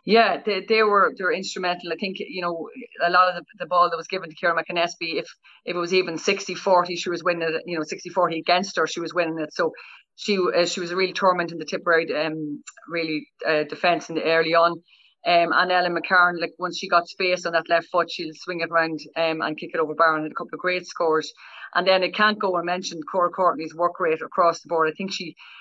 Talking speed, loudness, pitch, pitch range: 260 wpm, -23 LUFS, 175 Hz, 165-185 Hz